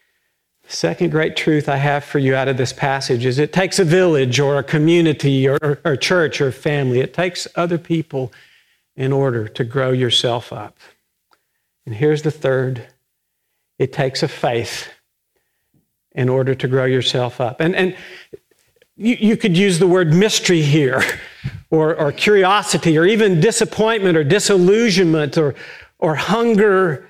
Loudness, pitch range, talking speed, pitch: -16 LUFS, 135-185 Hz, 155 wpm, 155 Hz